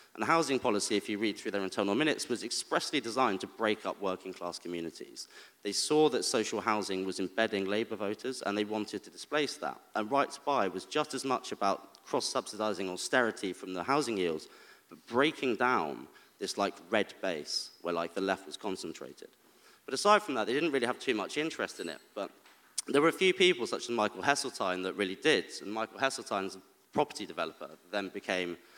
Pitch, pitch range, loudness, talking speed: 105 Hz, 95-130 Hz, -32 LUFS, 195 wpm